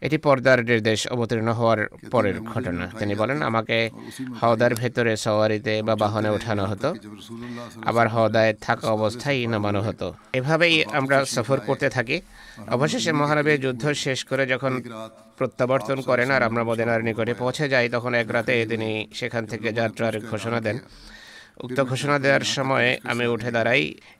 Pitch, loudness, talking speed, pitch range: 120 Hz, -23 LUFS, 140 wpm, 110-130 Hz